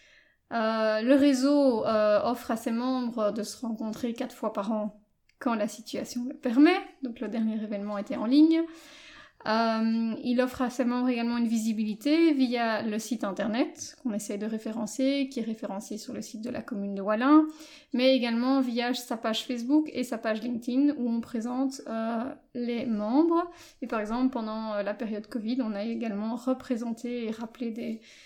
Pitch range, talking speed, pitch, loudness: 220-260 Hz, 180 wpm, 240 Hz, -28 LUFS